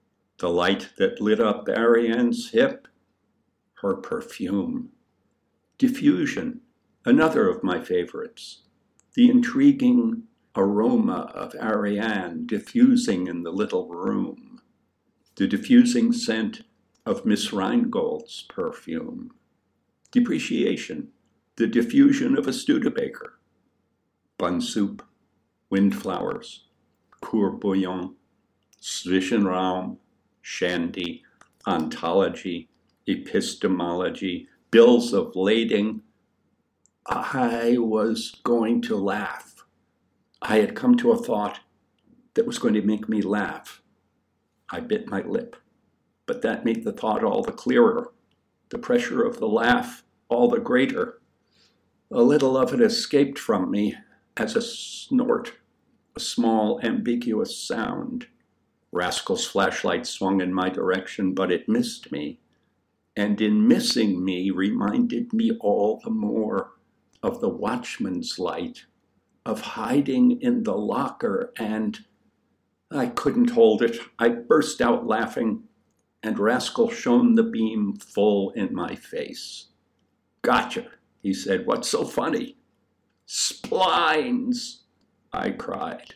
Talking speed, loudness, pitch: 110 wpm, -23 LUFS, 235 Hz